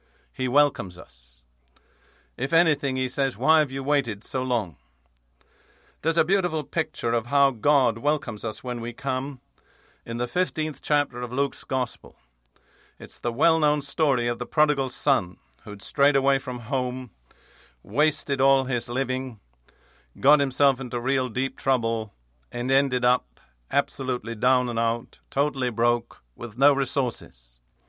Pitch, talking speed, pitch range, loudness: 130 Hz, 145 wpm, 115-140 Hz, -25 LUFS